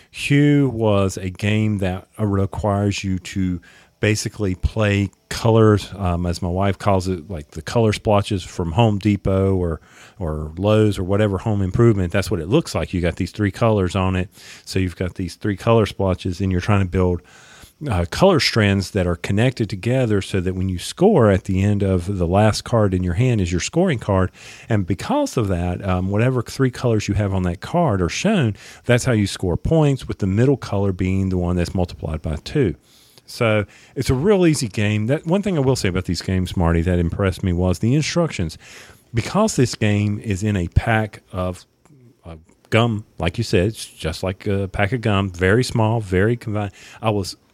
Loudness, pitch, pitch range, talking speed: -20 LUFS, 100 Hz, 95-115 Hz, 200 wpm